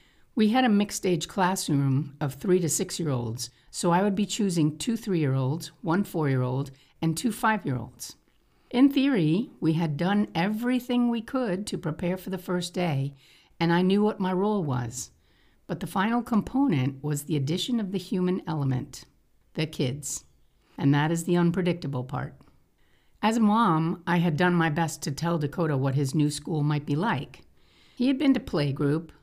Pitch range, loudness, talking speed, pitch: 150-205 Hz, -26 LUFS, 195 wpm, 170 Hz